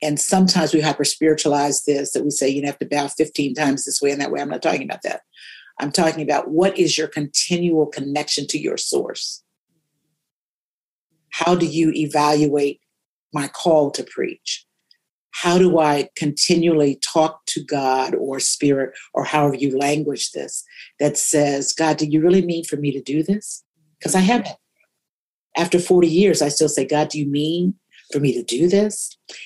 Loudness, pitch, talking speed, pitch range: -19 LUFS, 155 Hz, 175 wpm, 145-170 Hz